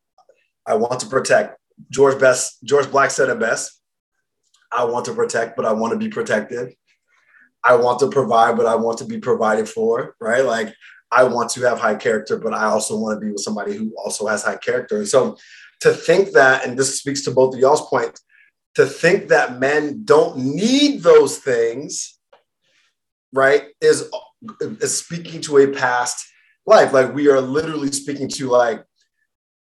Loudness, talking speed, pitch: -18 LUFS, 175 wpm, 155 Hz